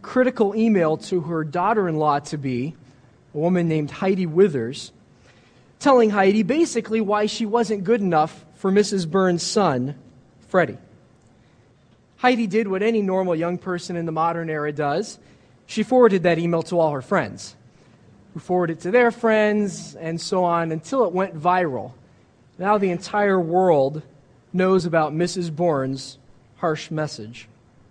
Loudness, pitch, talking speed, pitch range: -21 LUFS, 175 Hz, 150 wpm, 150-200 Hz